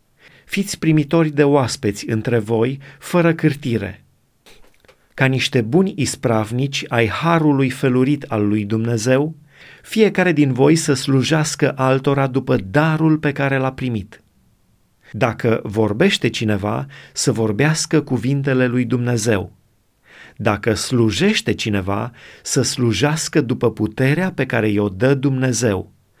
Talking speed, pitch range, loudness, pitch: 115 wpm, 115-150 Hz, -18 LUFS, 130 Hz